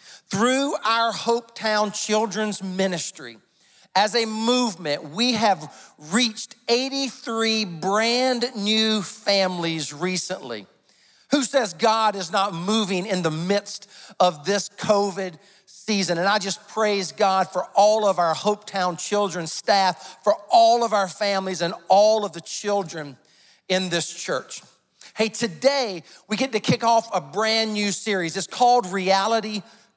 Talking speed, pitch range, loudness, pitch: 135 wpm, 185-225 Hz, -22 LUFS, 205 Hz